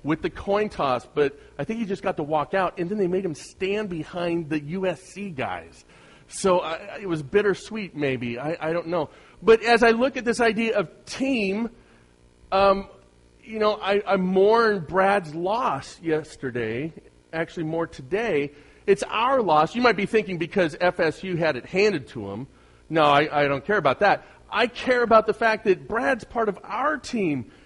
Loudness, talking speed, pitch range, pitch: -24 LUFS, 185 wpm, 155-210 Hz, 185 Hz